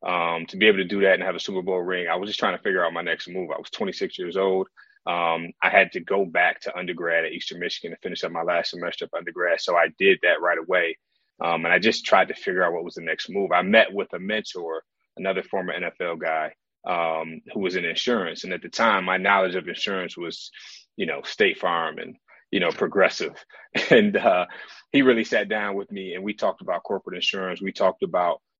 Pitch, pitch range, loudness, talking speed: 95 Hz, 85-100 Hz, -23 LUFS, 240 wpm